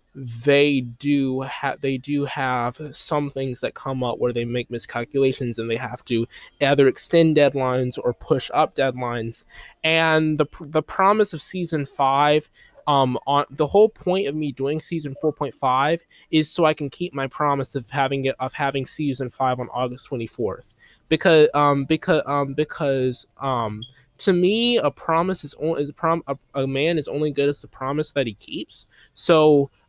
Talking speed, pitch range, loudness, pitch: 180 wpm, 130-155 Hz, -22 LUFS, 140 Hz